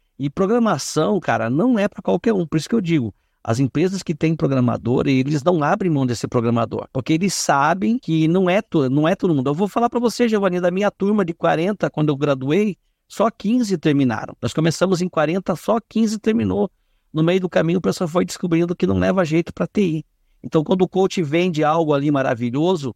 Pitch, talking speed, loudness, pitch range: 170 Hz, 210 wpm, -19 LUFS, 145-195 Hz